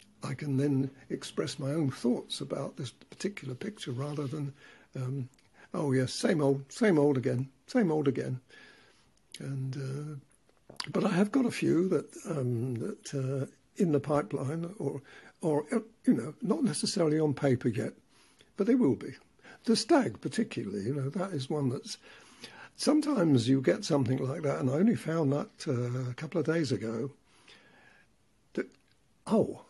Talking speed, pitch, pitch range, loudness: 160 wpm, 145 Hz, 135-180 Hz, -31 LUFS